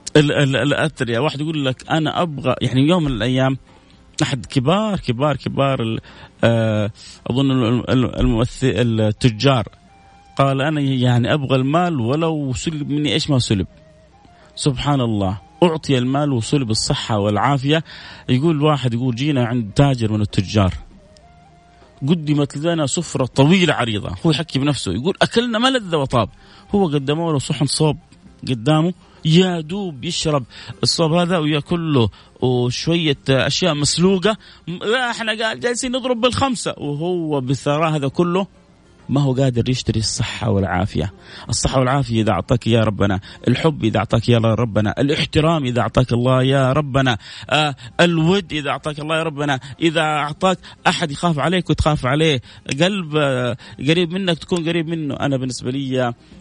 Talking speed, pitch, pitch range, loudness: 130 wpm, 140 Hz, 120-160 Hz, -18 LUFS